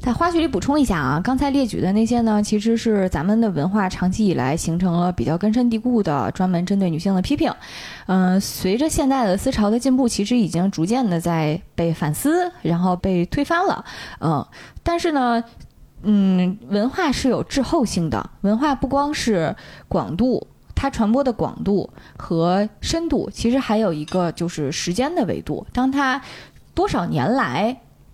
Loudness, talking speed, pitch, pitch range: -20 LUFS, 265 characters per minute, 210 Hz, 180-265 Hz